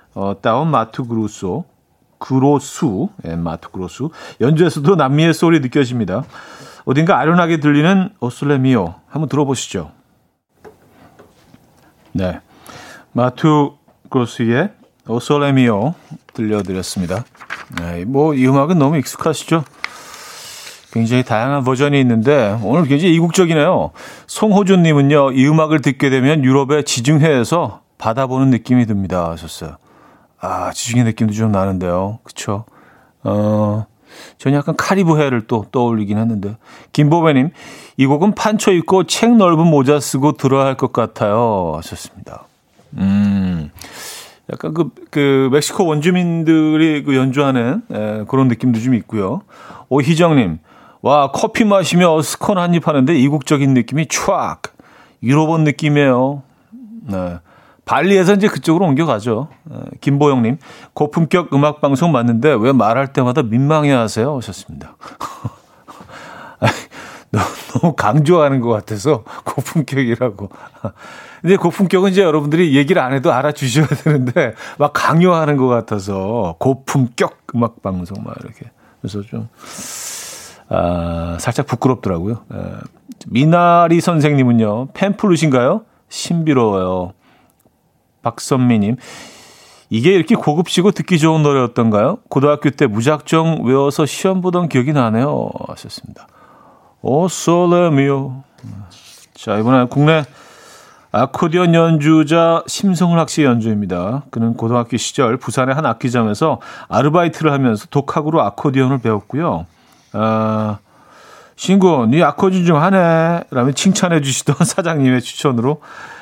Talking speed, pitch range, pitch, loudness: 290 characters per minute, 115-160 Hz, 140 Hz, -15 LUFS